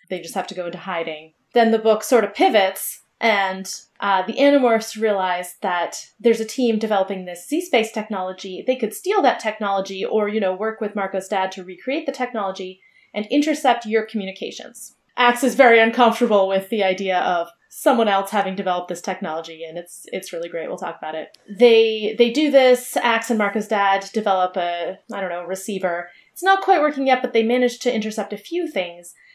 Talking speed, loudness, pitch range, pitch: 195 wpm, -20 LUFS, 190-240 Hz, 210 Hz